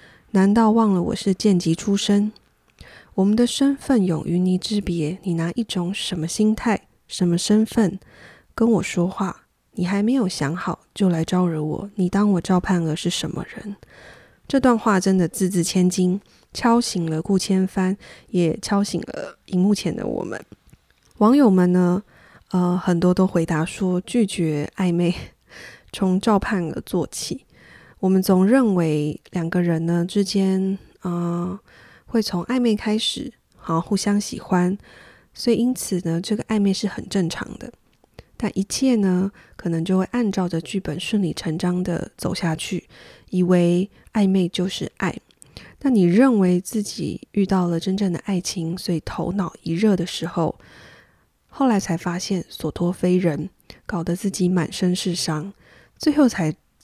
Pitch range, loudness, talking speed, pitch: 175-205 Hz, -21 LUFS, 225 characters per minute, 185 Hz